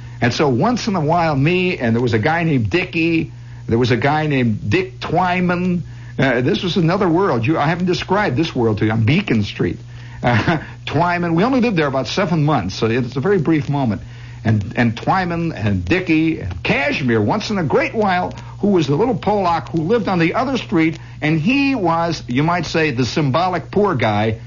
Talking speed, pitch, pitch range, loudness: 205 wpm, 150 Hz, 120-170 Hz, -17 LUFS